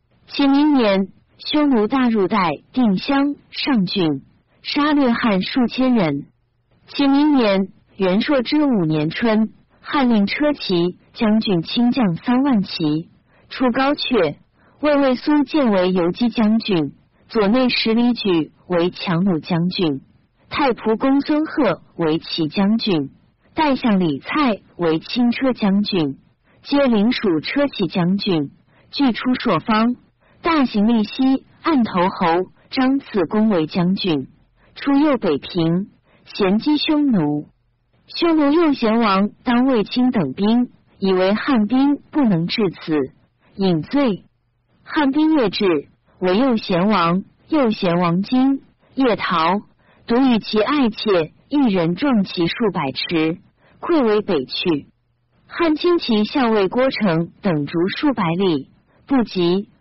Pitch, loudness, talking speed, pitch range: 215 Hz, -18 LUFS, 180 characters per minute, 175-265 Hz